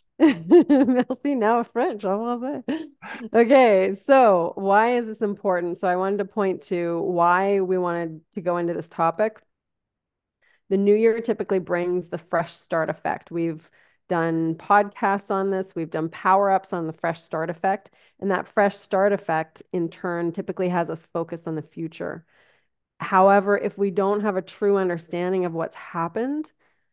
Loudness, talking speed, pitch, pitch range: -22 LUFS, 165 wpm, 190 Hz, 170-210 Hz